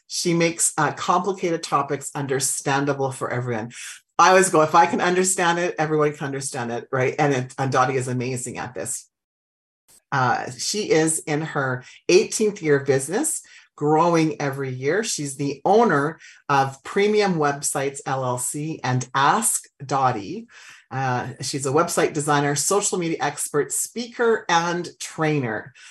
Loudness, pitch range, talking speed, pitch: -22 LUFS, 135-170 Hz, 145 wpm, 145 Hz